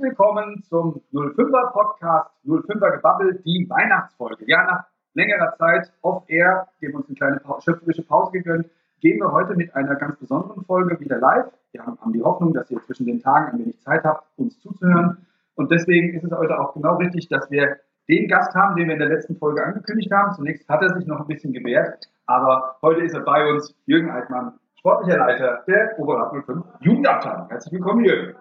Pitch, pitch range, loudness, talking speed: 170 Hz, 155-205 Hz, -20 LUFS, 190 wpm